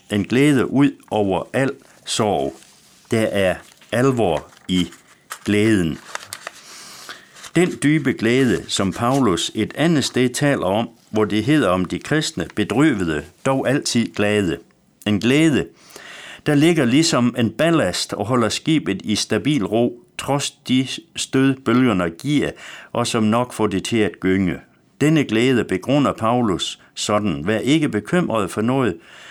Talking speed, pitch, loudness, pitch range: 135 wpm, 120 Hz, -19 LUFS, 105-140 Hz